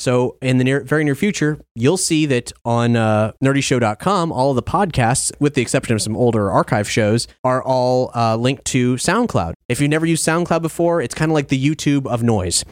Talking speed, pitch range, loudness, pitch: 210 wpm, 120-150 Hz, -17 LUFS, 130 Hz